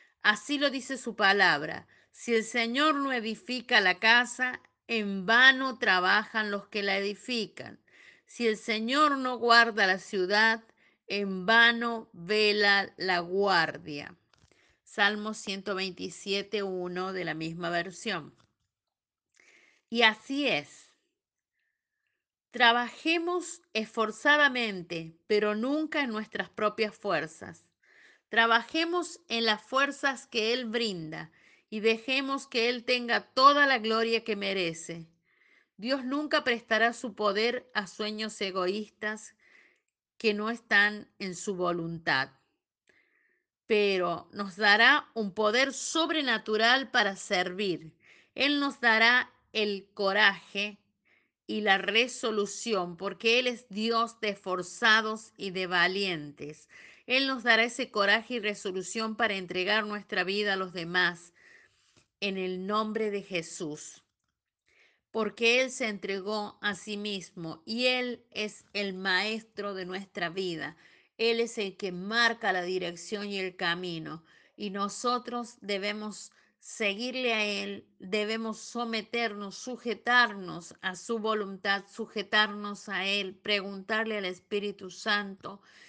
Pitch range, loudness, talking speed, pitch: 195-235 Hz, -28 LUFS, 115 wpm, 215 Hz